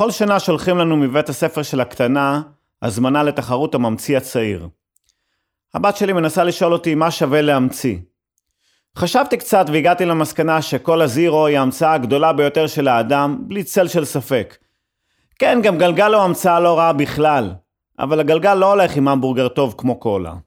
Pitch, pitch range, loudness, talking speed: 150 Hz, 130-170 Hz, -16 LUFS, 155 wpm